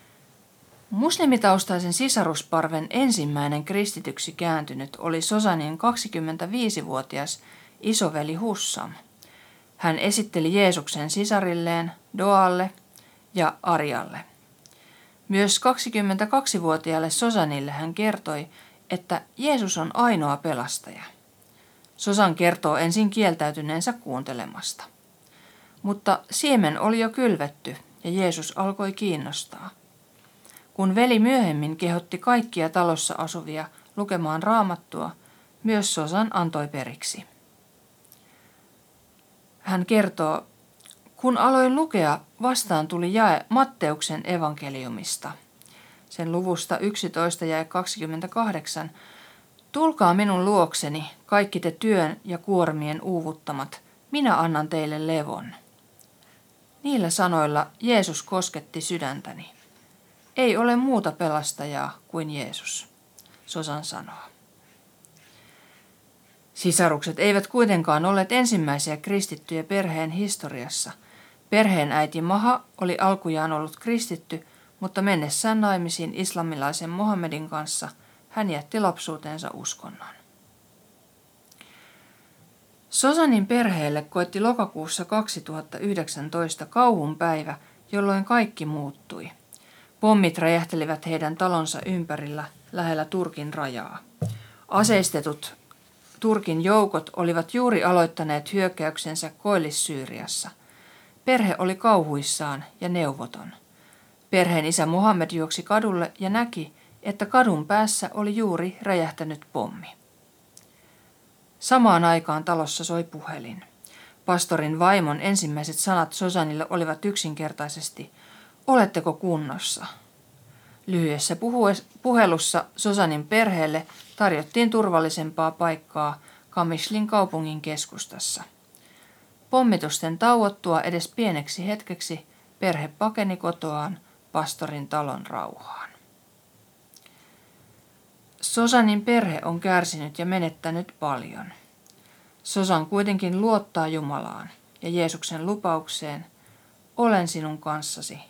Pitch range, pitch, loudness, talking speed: 155-205 Hz, 175 Hz, -24 LUFS, 90 wpm